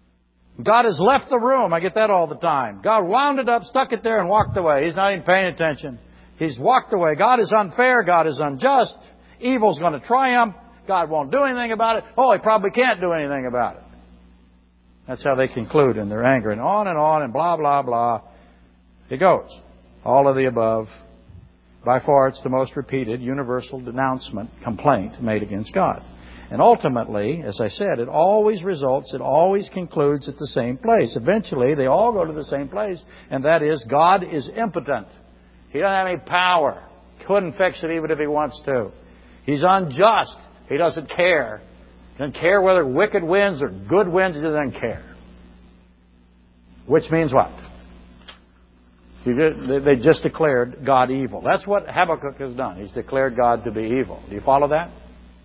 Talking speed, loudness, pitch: 185 wpm, -20 LUFS, 140 Hz